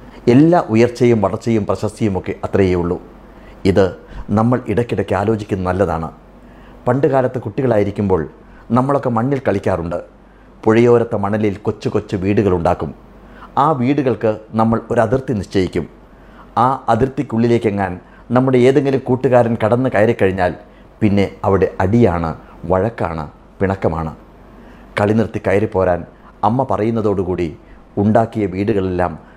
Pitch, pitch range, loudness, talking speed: 105 Hz, 95-120 Hz, -16 LUFS, 95 wpm